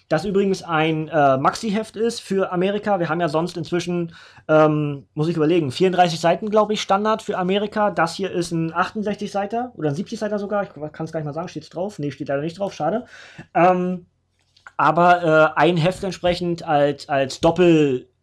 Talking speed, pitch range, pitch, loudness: 200 wpm, 155-195 Hz, 175 Hz, -20 LUFS